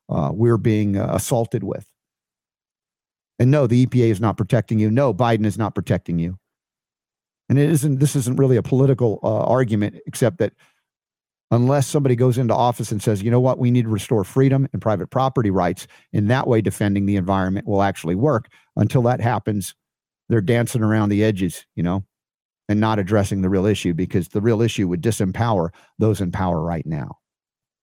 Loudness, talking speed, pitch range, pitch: -20 LUFS, 190 wpm, 100-125 Hz, 110 Hz